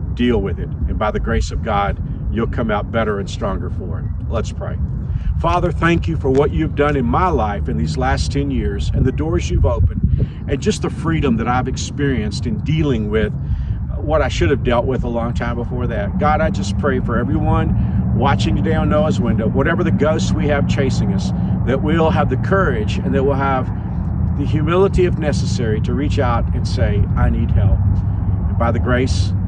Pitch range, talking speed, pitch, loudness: 90-115 Hz, 210 wpm, 100 Hz, -18 LUFS